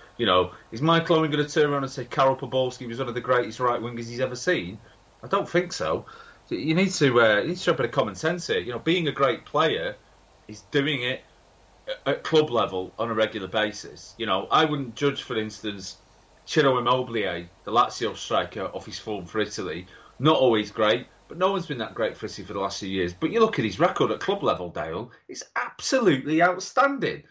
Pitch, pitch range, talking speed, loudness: 125 Hz, 110-155 Hz, 220 wpm, -25 LUFS